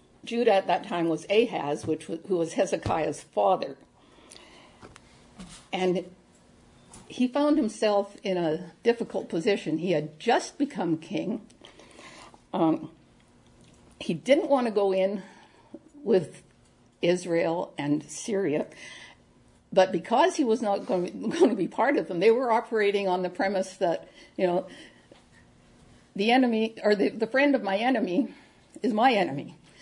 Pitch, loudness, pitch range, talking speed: 195 Hz, -26 LUFS, 175-230 Hz, 145 wpm